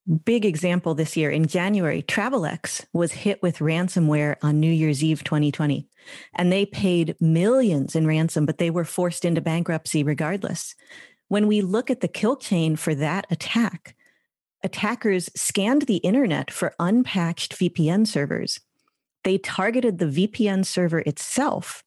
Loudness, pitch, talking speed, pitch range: -23 LUFS, 175 Hz, 145 wpm, 160-200 Hz